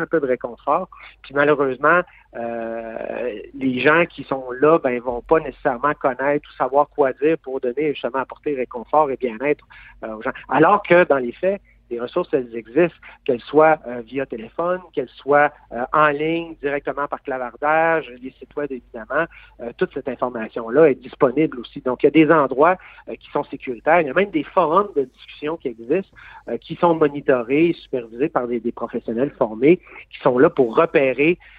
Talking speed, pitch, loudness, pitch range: 190 wpm, 145 Hz, -20 LUFS, 125-160 Hz